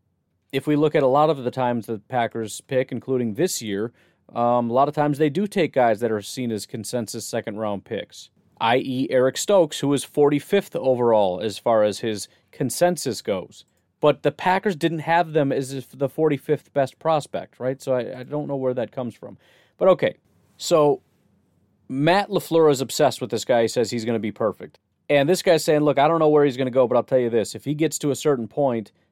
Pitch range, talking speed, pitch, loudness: 115-150 Hz, 225 wpm, 130 Hz, -22 LUFS